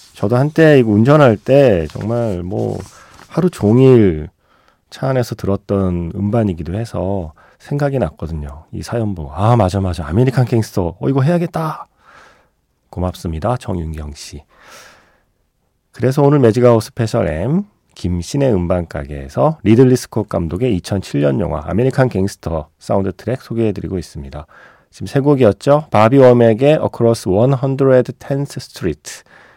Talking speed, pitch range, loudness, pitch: 300 characters per minute, 90-130 Hz, -15 LUFS, 110 Hz